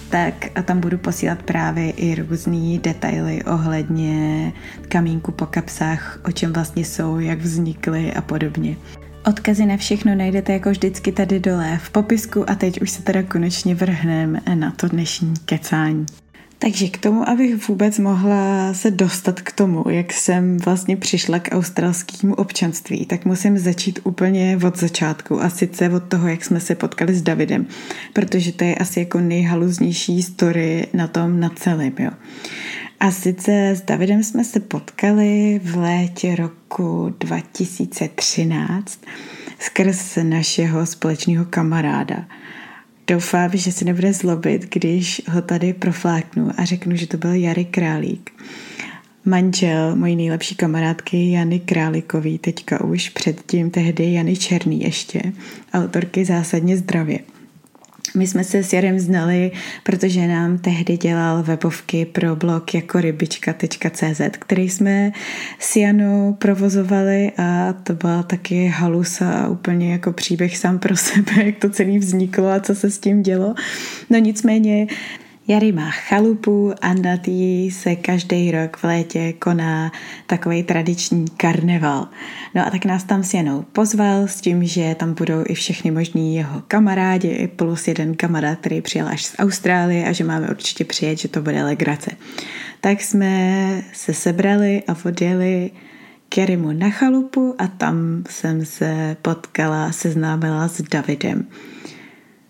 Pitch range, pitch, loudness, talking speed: 165-195 Hz, 180 Hz, -19 LUFS, 145 wpm